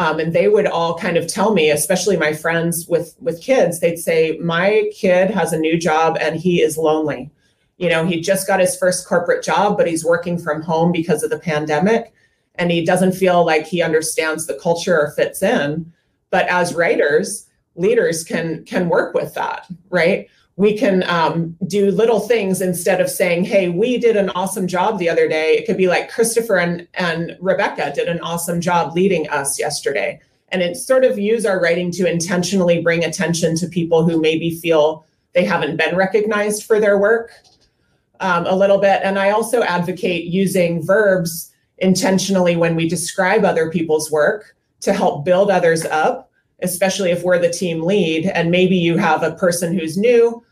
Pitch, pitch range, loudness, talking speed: 175 Hz, 165-195 Hz, -17 LUFS, 190 wpm